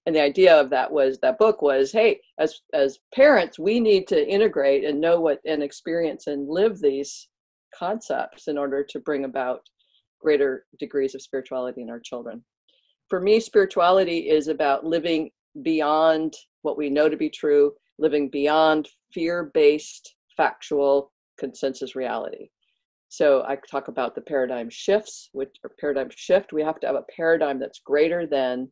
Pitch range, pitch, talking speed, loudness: 140-190 Hz, 155 Hz, 165 wpm, -22 LUFS